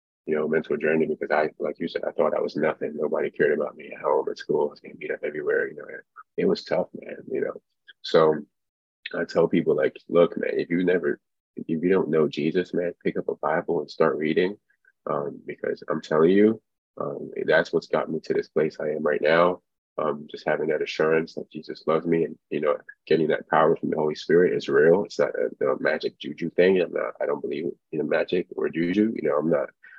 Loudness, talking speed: -25 LUFS, 235 wpm